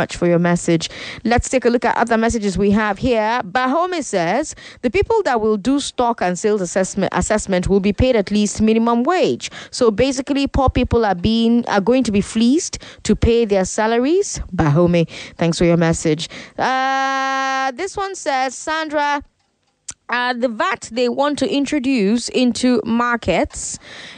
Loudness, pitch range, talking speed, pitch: -18 LUFS, 200-265 Hz, 165 wpm, 235 Hz